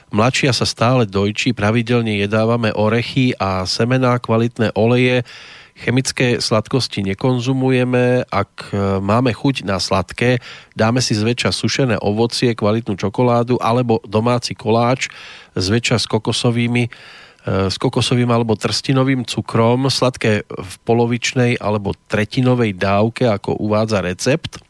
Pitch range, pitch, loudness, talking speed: 105-125 Hz, 115 Hz, -17 LUFS, 110 wpm